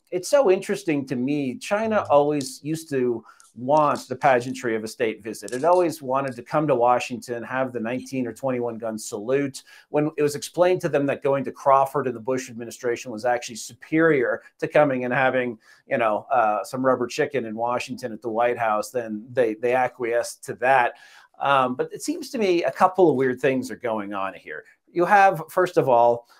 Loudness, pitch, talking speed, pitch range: -23 LUFS, 130 Hz, 200 wpm, 120-155 Hz